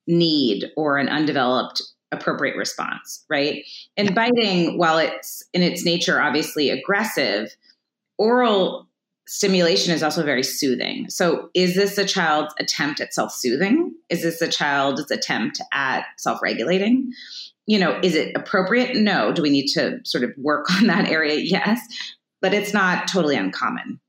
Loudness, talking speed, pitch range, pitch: -20 LUFS, 150 wpm, 150-205 Hz, 180 Hz